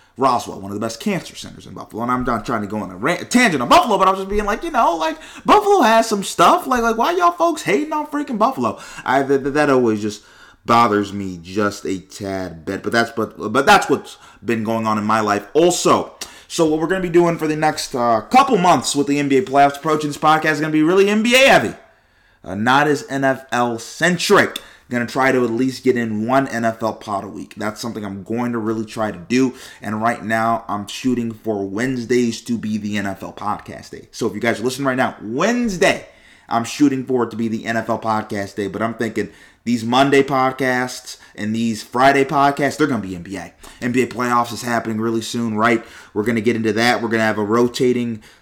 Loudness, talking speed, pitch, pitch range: -18 LUFS, 235 wpm, 120 Hz, 110-145 Hz